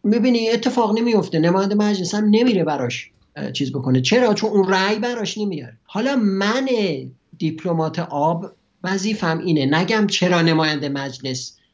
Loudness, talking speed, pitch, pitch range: -19 LUFS, 135 wpm, 185 Hz, 150-215 Hz